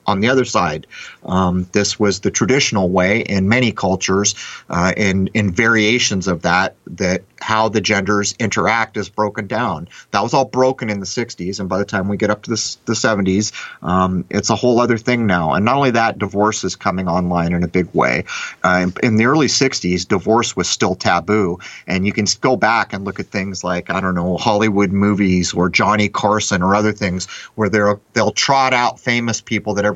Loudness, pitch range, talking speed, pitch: -16 LUFS, 95-115 Hz, 205 wpm, 105 Hz